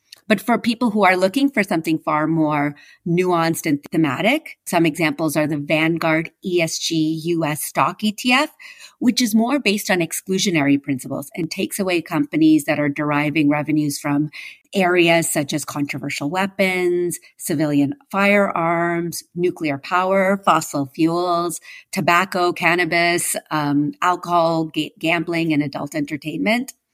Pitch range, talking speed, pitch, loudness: 155-190 Hz, 130 wpm, 170 Hz, -19 LUFS